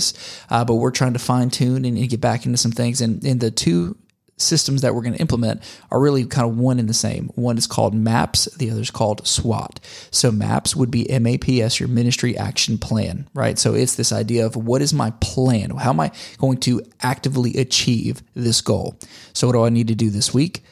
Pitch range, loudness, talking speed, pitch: 115-130 Hz, -19 LUFS, 225 wpm, 120 Hz